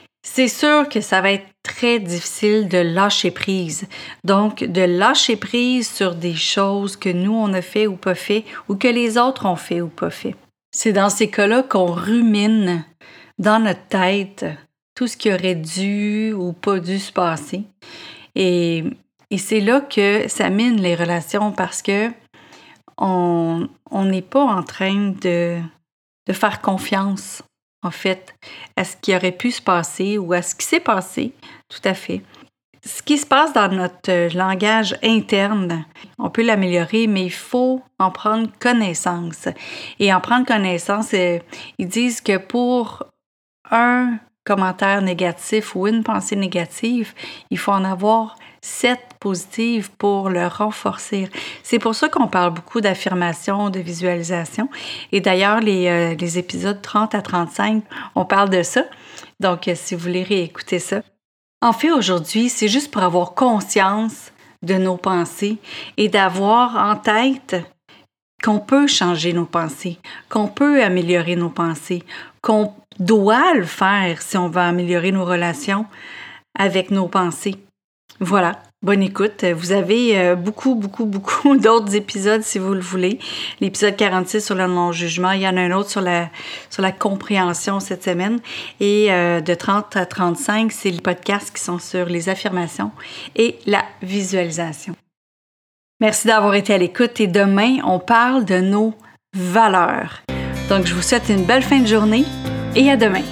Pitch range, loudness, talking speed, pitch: 180-220 Hz, -18 LUFS, 160 wpm, 200 Hz